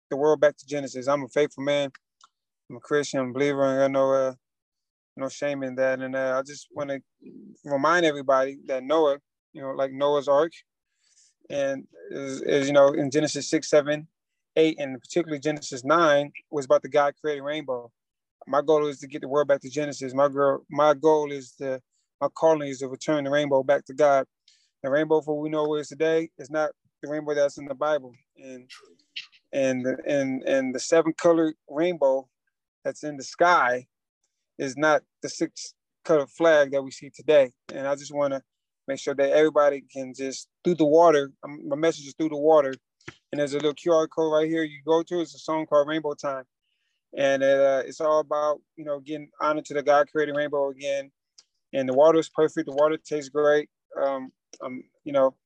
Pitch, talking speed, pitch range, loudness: 145 Hz, 205 wpm, 135-155 Hz, -24 LUFS